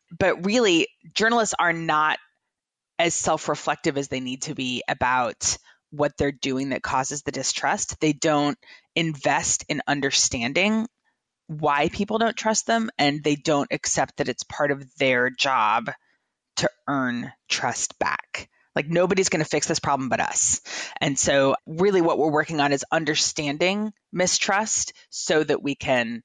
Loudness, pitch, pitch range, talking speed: -23 LUFS, 155 Hz, 140-180 Hz, 155 wpm